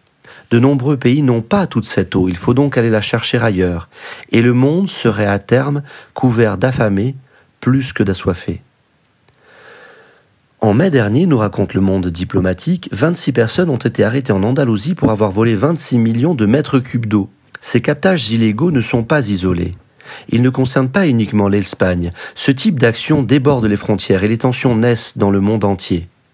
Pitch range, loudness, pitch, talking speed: 100-135 Hz, -15 LUFS, 115 Hz, 175 wpm